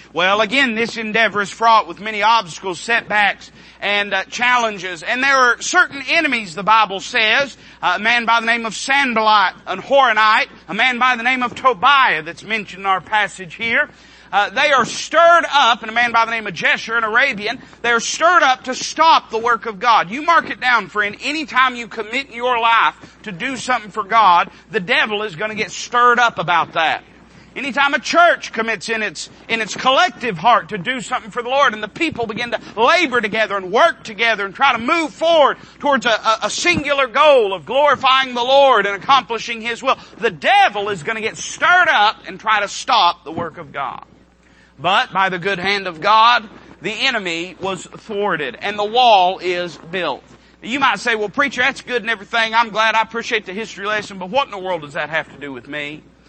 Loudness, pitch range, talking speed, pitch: -16 LUFS, 205-260 Hz, 210 wpm, 230 Hz